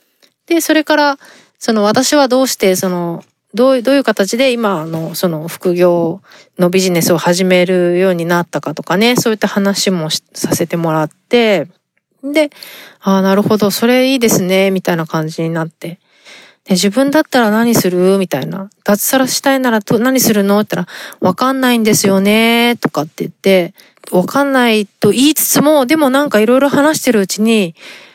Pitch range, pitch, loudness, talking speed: 180-255 Hz, 205 Hz, -12 LUFS, 345 characters per minute